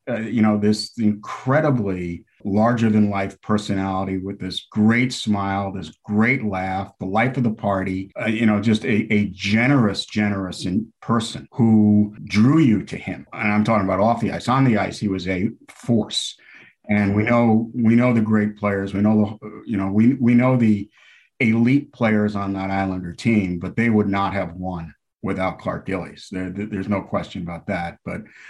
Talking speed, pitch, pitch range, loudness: 175 wpm, 105 Hz, 95-115 Hz, -20 LUFS